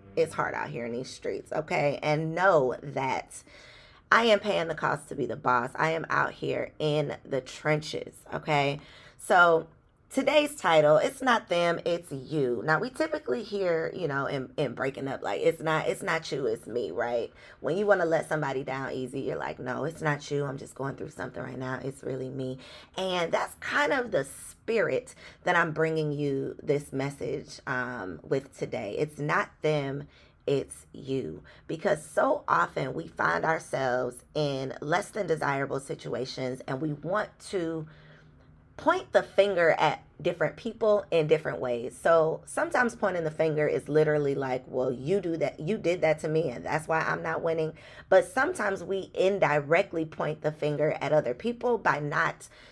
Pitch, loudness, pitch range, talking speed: 155 Hz, -28 LUFS, 140-185 Hz, 180 wpm